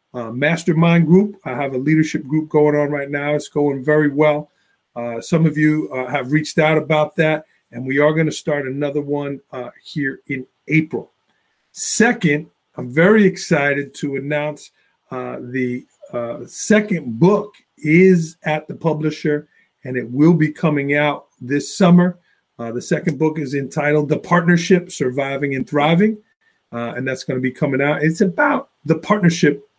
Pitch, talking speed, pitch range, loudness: 150 Hz, 170 wpm, 140-165 Hz, -18 LUFS